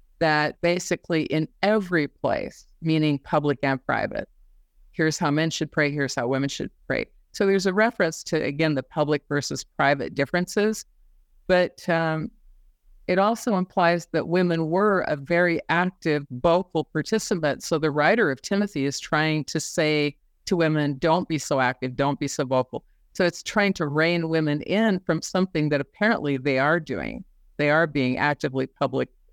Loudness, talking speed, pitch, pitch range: -24 LUFS, 165 wpm, 160 Hz, 145-180 Hz